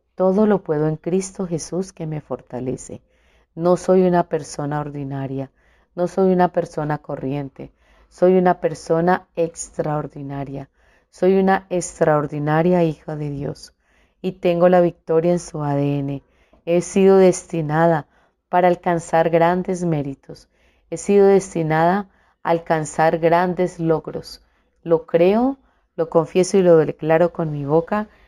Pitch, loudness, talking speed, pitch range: 165 Hz, -19 LUFS, 125 wpm, 150-180 Hz